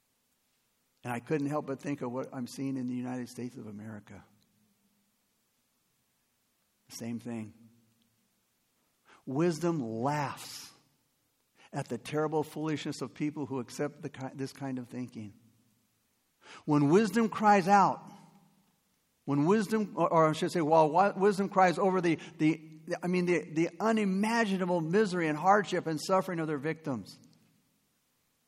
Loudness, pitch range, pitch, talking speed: -30 LUFS, 125-180 Hz, 150 Hz, 135 wpm